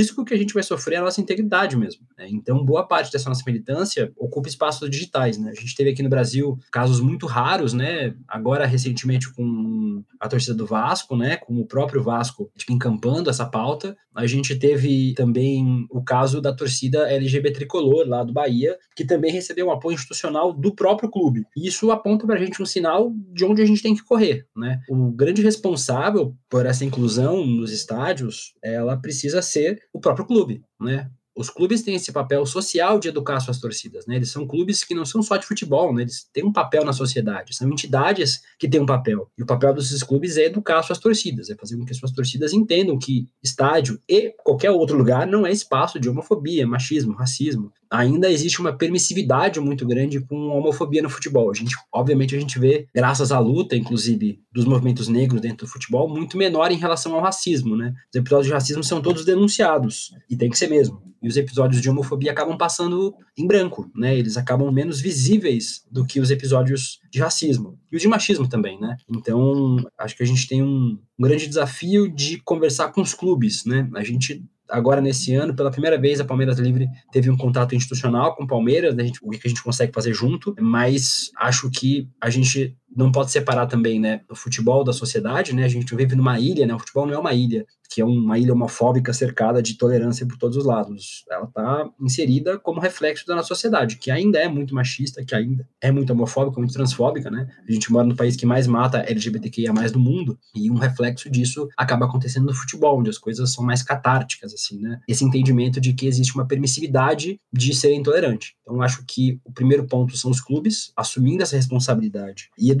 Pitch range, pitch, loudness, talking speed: 120-155 Hz, 130 Hz, -21 LUFS, 205 wpm